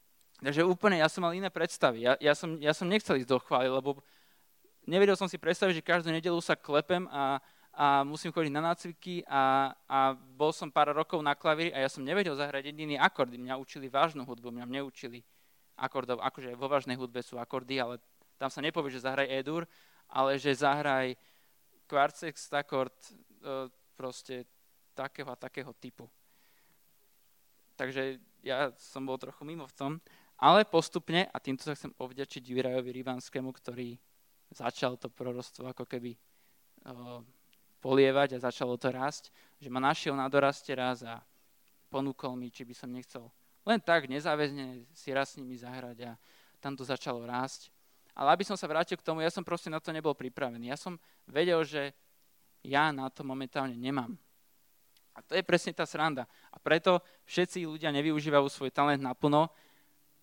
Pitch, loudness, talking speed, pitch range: 140 Hz, -32 LUFS, 165 wpm, 130-160 Hz